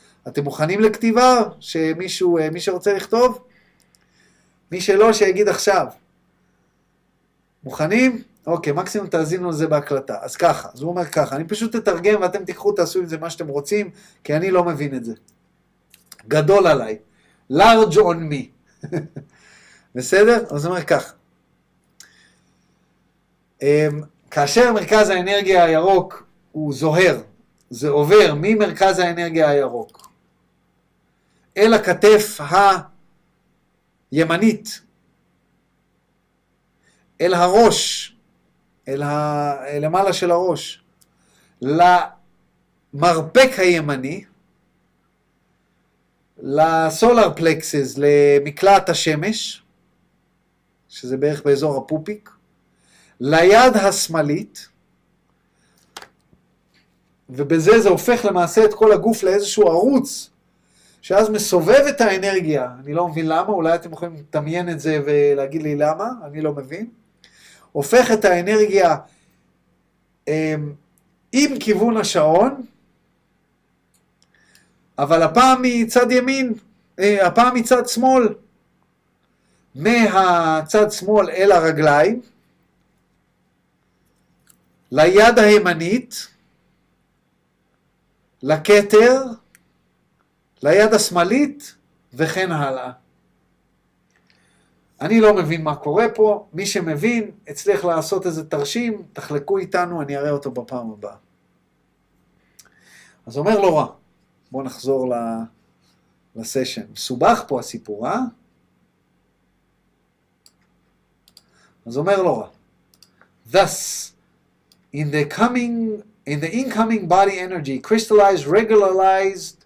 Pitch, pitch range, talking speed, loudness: 180 Hz, 150-215 Hz, 90 wpm, -17 LUFS